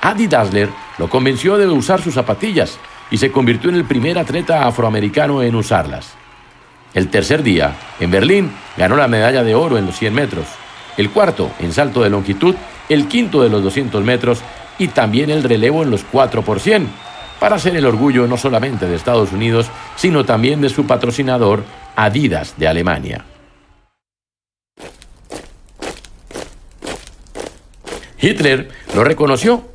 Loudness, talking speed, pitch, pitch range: -15 LUFS, 145 wpm, 125 Hz, 110-155 Hz